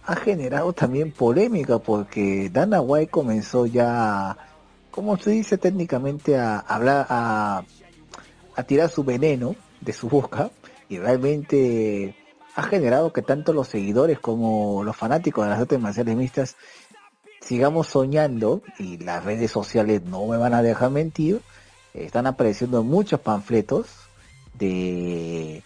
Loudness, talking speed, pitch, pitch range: -22 LUFS, 135 wpm, 125 Hz, 110-150 Hz